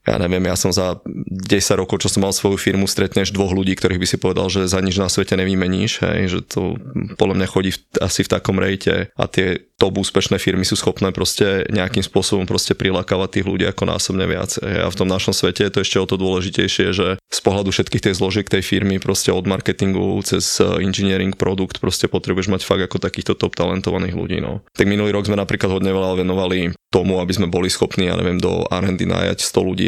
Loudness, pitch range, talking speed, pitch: -18 LUFS, 95-100 Hz, 220 wpm, 95 Hz